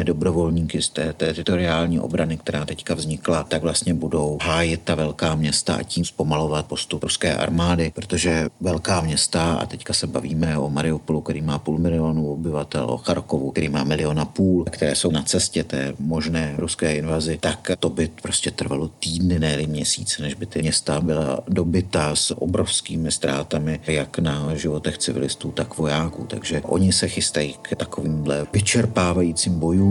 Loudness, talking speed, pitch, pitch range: -22 LUFS, 160 wpm, 80 Hz, 75-85 Hz